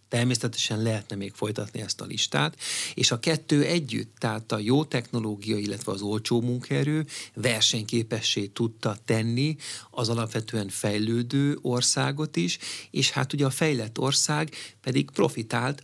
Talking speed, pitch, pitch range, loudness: 135 wpm, 120 Hz, 110-135 Hz, -26 LUFS